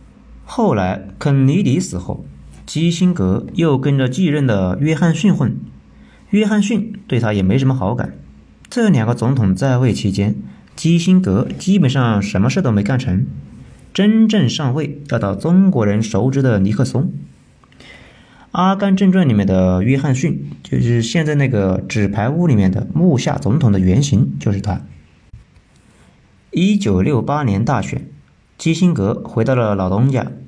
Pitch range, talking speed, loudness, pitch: 100-165 Hz, 230 characters per minute, -16 LUFS, 125 Hz